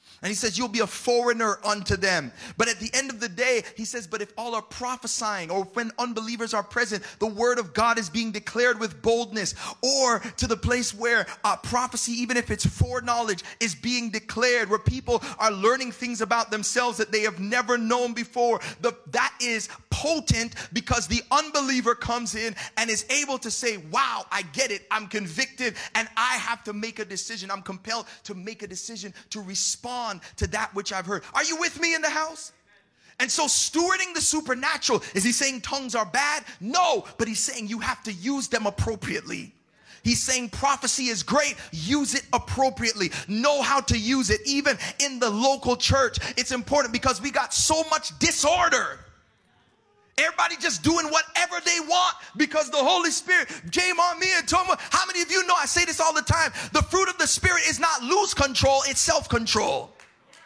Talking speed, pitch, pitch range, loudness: 195 wpm, 240 Hz, 220-285 Hz, -24 LUFS